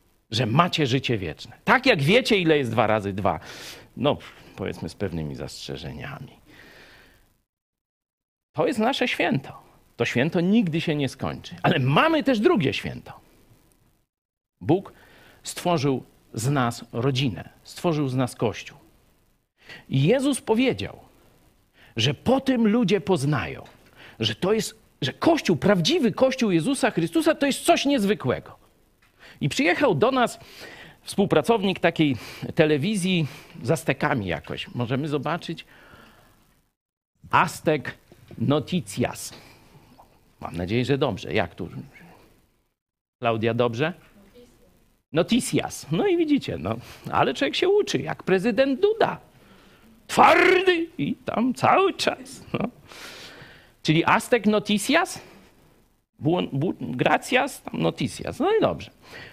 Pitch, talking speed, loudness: 165 Hz, 115 wpm, -23 LUFS